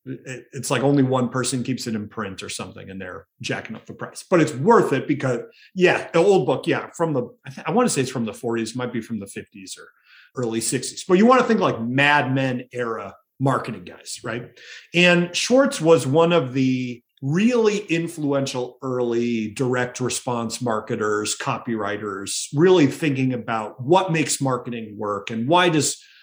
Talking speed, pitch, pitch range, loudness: 190 wpm, 130 Hz, 120-165 Hz, -21 LUFS